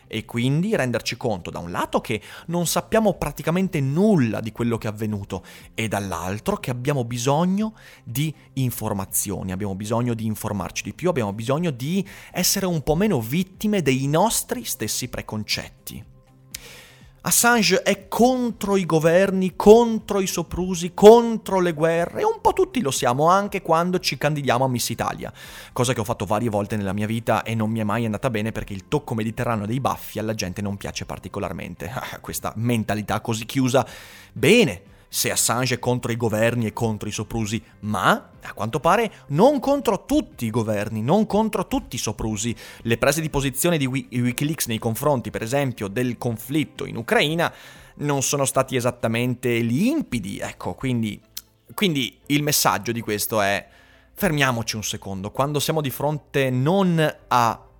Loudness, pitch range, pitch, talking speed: -22 LUFS, 110-170 Hz, 125 Hz, 165 wpm